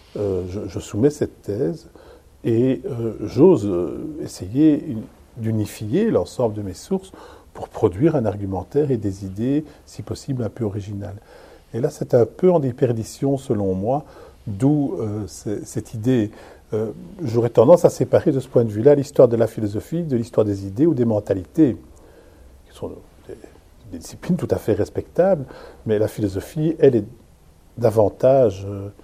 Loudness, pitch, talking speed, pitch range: -20 LUFS, 115 Hz, 165 wpm, 105-135 Hz